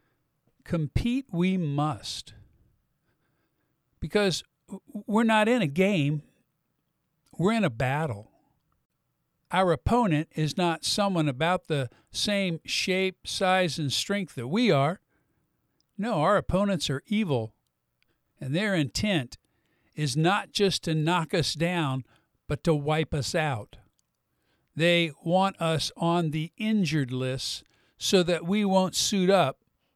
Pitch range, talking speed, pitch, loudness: 145-190 Hz, 120 wpm, 165 Hz, -26 LUFS